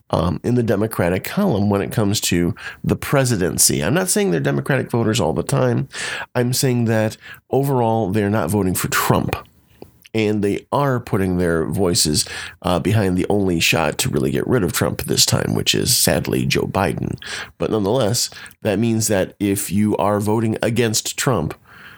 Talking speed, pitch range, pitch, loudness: 175 wpm, 95-115 Hz, 105 Hz, -19 LUFS